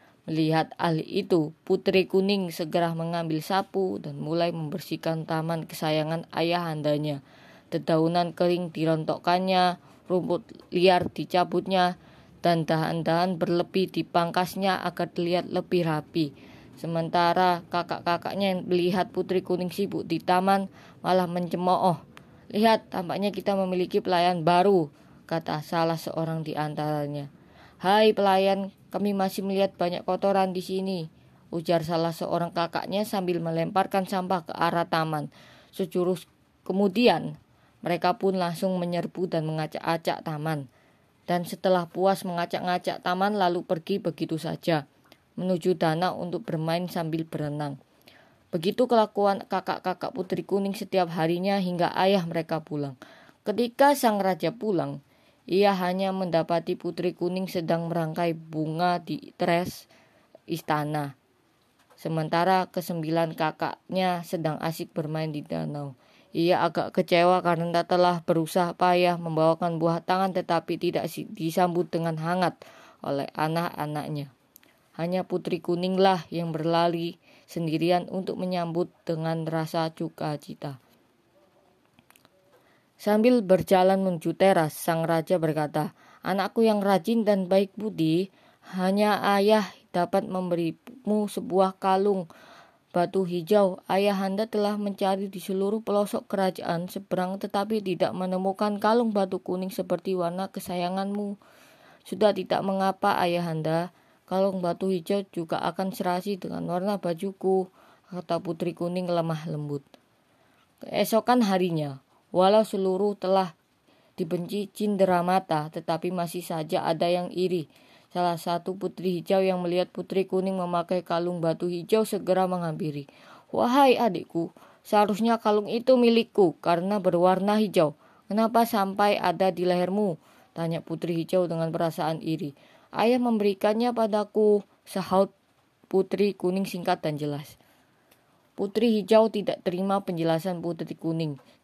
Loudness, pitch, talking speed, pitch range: -26 LUFS, 180 Hz, 115 wpm, 165-195 Hz